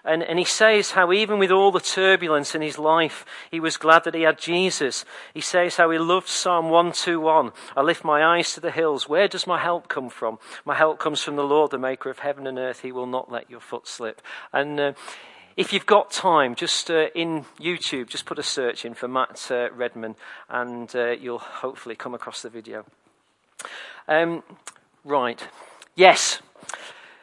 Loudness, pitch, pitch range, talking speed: -22 LUFS, 160 Hz, 135-175 Hz, 195 wpm